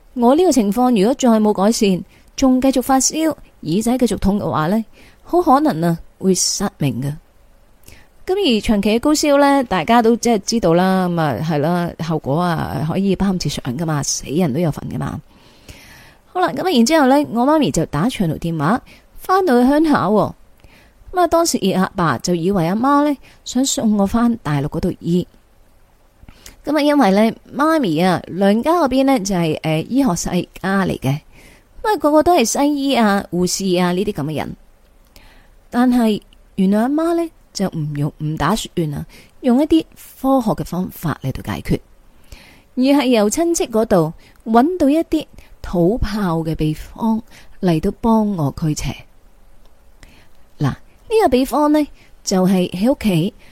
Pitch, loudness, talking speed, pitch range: 210 Hz, -17 LUFS, 240 characters per minute, 170-270 Hz